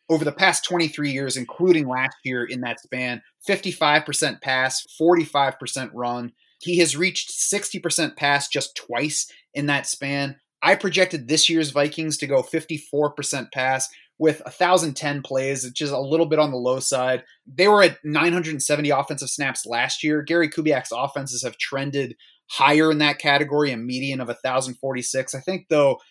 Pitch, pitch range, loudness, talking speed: 145 Hz, 130-160 Hz, -22 LUFS, 160 wpm